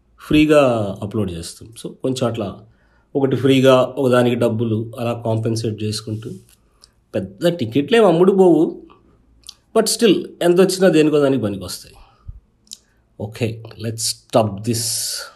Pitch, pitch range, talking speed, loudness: 120 Hz, 110-145 Hz, 115 wpm, -17 LUFS